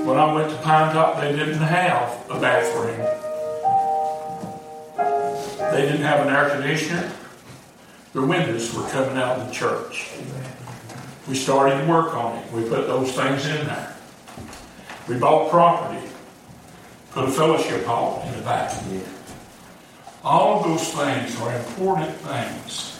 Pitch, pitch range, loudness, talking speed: 145 Hz, 130-155 Hz, -22 LUFS, 140 wpm